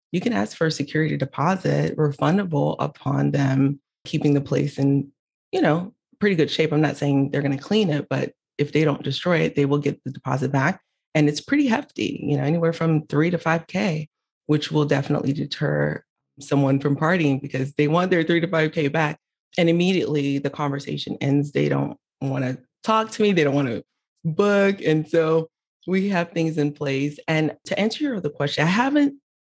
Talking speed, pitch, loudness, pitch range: 200 wpm, 150 Hz, -22 LUFS, 140-170 Hz